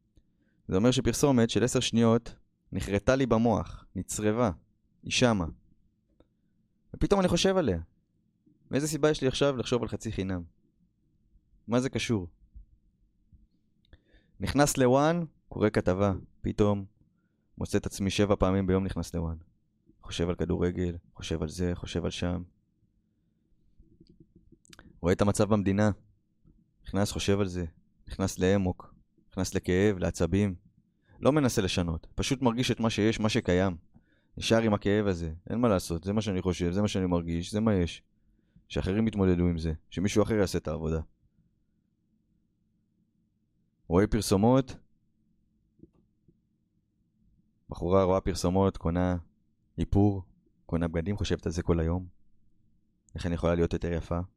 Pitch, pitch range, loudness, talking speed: 100 Hz, 90-110 Hz, -28 LUFS, 130 wpm